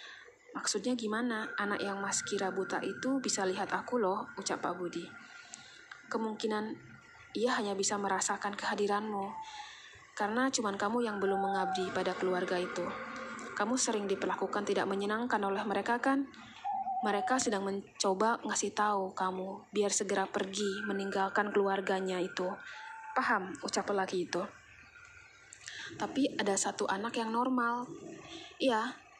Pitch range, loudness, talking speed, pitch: 195-240 Hz, -34 LUFS, 125 wpm, 205 Hz